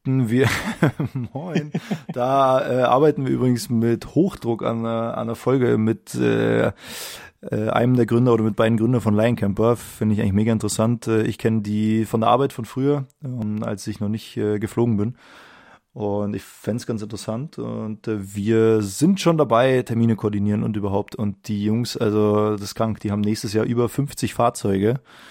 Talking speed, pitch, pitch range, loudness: 180 wpm, 115 Hz, 105-125 Hz, -21 LUFS